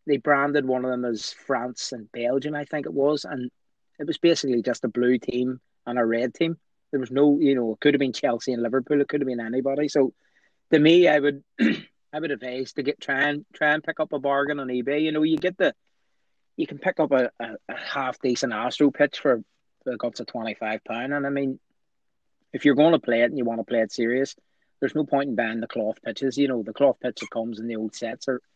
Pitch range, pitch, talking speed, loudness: 125-145 Hz, 135 Hz, 245 wpm, -24 LUFS